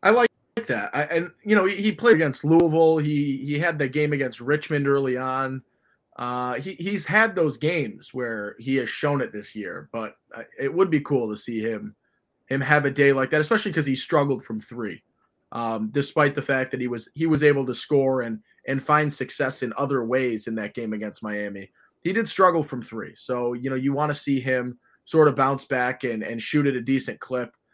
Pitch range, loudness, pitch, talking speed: 125-150 Hz, -24 LUFS, 135 Hz, 220 wpm